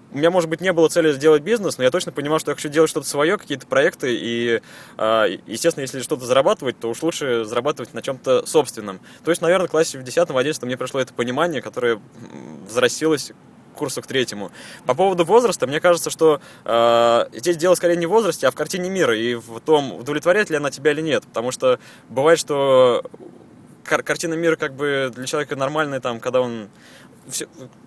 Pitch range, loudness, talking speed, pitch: 130-165 Hz, -20 LUFS, 195 wpm, 150 Hz